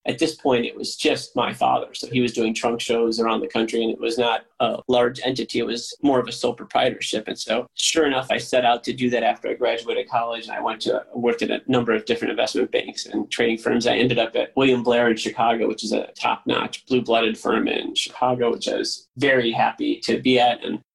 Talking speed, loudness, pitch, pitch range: 245 wpm, -22 LUFS, 120 Hz, 115-125 Hz